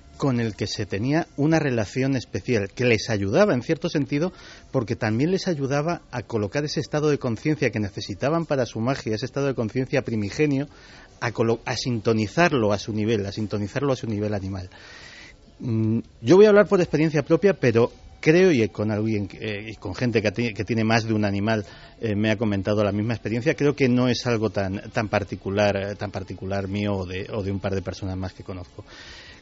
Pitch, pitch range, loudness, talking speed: 115 Hz, 105-135 Hz, -23 LUFS, 195 wpm